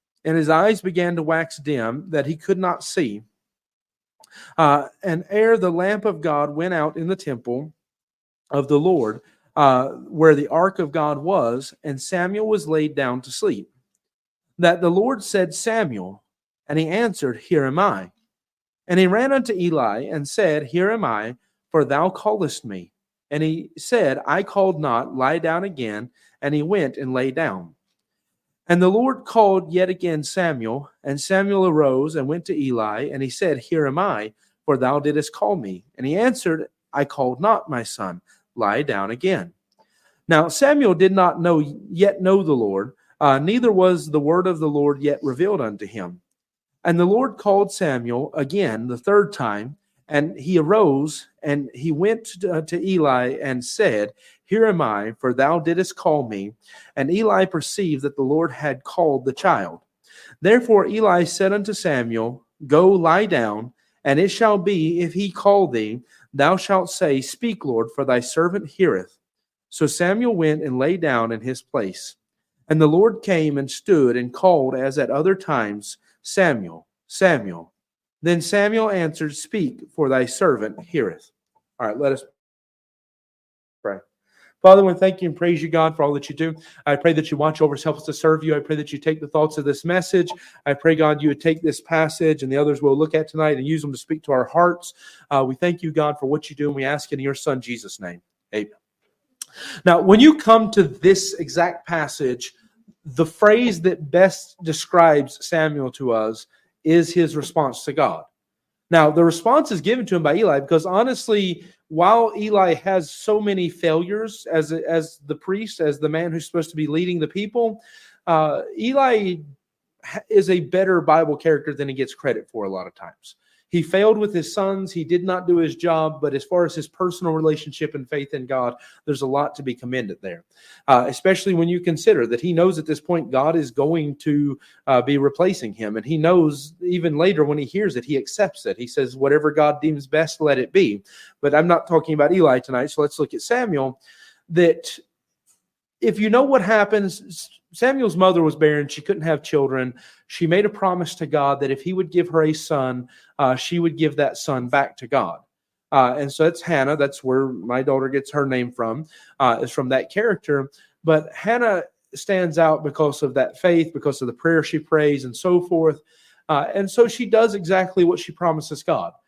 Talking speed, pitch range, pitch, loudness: 195 wpm, 140-185 Hz, 160 Hz, -20 LUFS